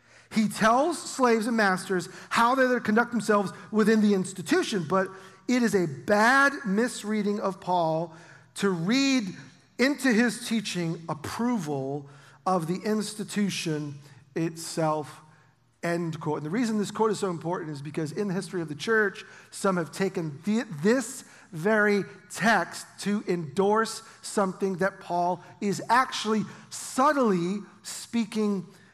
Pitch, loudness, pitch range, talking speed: 195 Hz, -27 LUFS, 170-220 Hz, 135 wpm